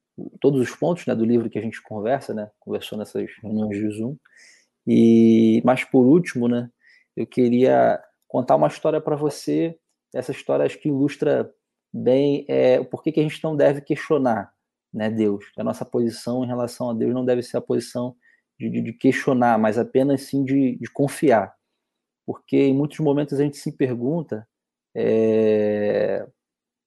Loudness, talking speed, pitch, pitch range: -21 LUFS, 170 wpm, 125 Hz, 110-140 Hz